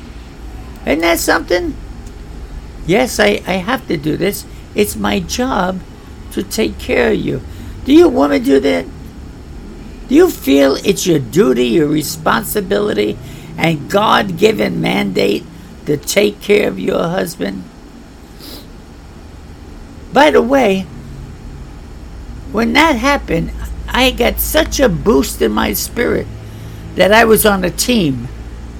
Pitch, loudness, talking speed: 150 Hz, -14 LUFS, 130 wpm